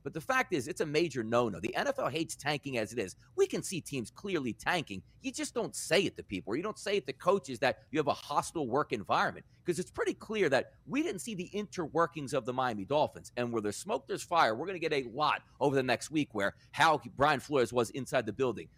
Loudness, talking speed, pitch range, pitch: -33 LUFS, 255 wpm, 120-180 Hz, 145 Hz